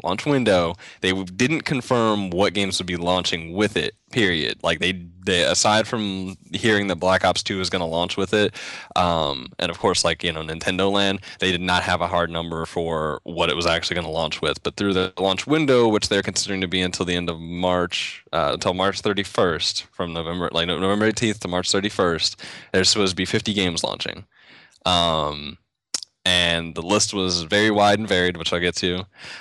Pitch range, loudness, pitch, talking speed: 85-100 Hz, -21 LUFS, 95 Hz, 205 wpm